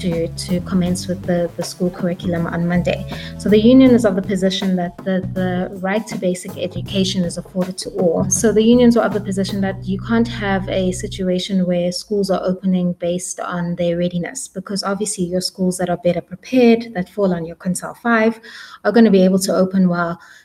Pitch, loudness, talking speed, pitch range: 185 Hz, -18 LUFS, 210 wpm, 175-200 Hz